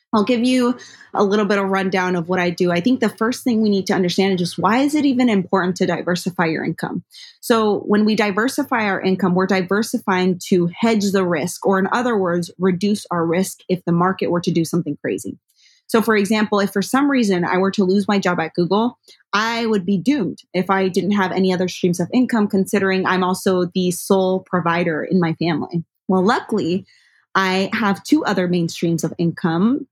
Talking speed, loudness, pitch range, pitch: 215 wpm, -19 LUFS, 180-215 Hz, 190 Hz